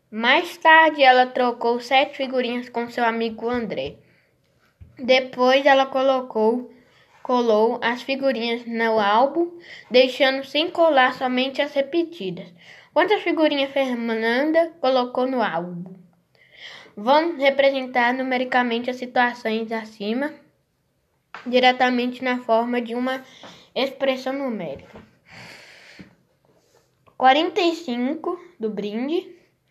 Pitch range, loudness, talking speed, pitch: 235-275 Hz, -21 LUFS, 95 wpm, 255 Hz